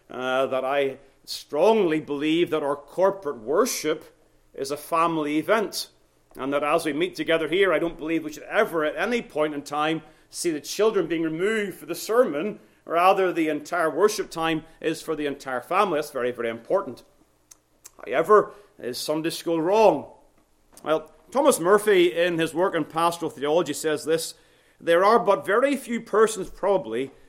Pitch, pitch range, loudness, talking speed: 160 Hz, 150-185 Hz, -24 LUFS, 165 wpm